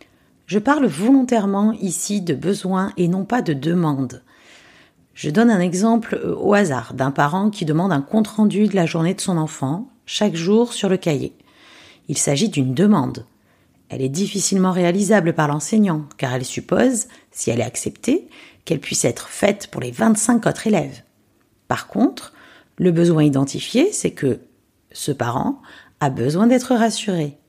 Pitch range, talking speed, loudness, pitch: 155-220 Hz, 160 wpm, -19 LUFS, 190 Hz